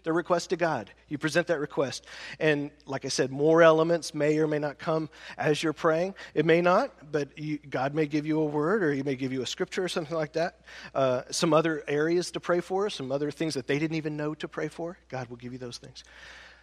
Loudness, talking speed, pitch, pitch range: -28 LUFS, 245 wpm, 155 Hz, 145-165 Hz